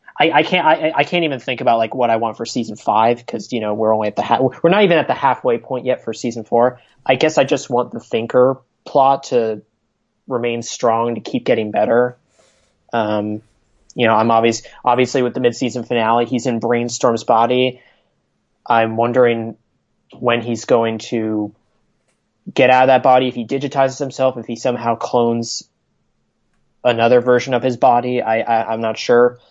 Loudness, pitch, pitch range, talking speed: -17 LUFS, 120 Hz, 115-125 Hz, 190 wpm